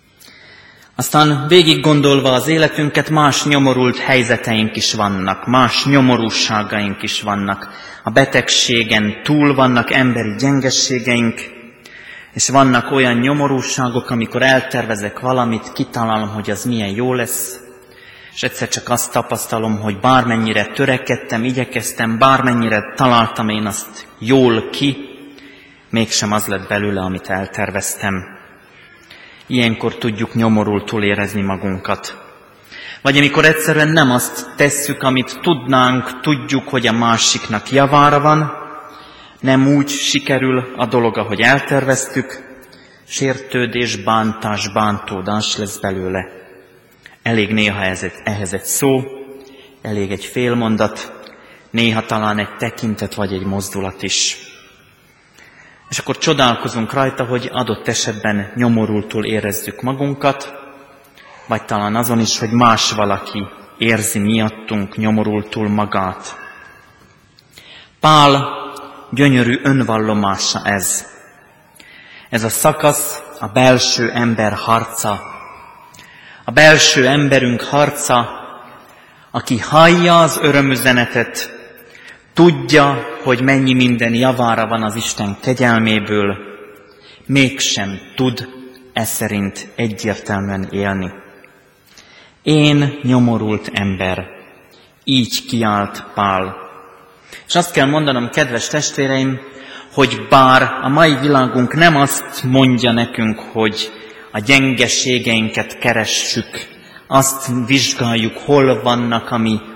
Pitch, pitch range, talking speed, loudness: 120 Hz, 105-135 Hz, 105 wpm, -15 LUFS